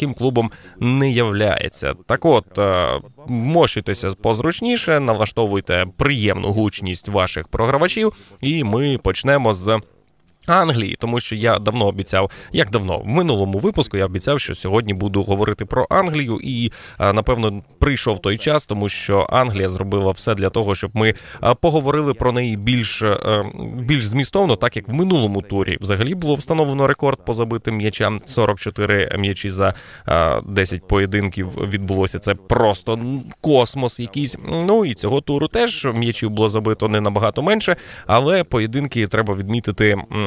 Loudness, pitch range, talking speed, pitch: -19 LUFS, 100-135 Hz, 140 wpm, 110 Hz